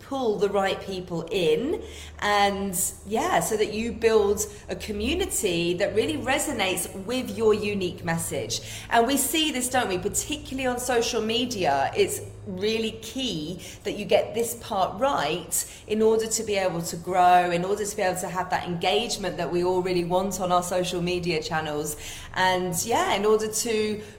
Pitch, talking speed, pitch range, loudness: 205 Hz, 175 wpm, 180-230 Hz, -25 LUFS